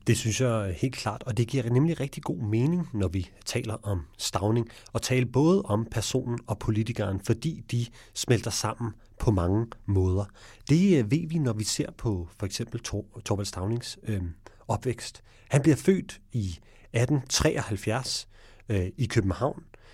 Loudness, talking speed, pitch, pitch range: -28 LUFS, 160 wpm, 115 Hz, 105-130 Hz